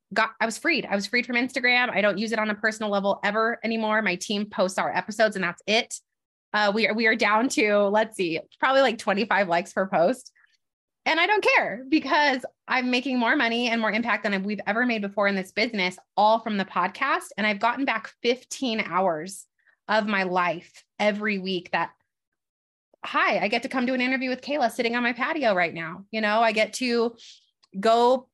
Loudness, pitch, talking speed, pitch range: -24 LUFS, 220 Hz, 215 wpm, 200-245 Hz